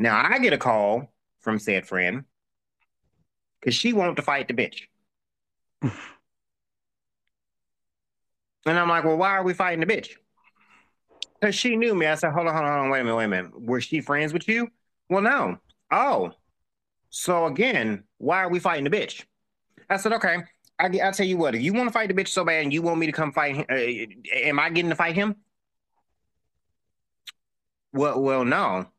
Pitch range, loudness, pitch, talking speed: 135-195 Hz, -24 LUFS, 165 Hz, 195 wpm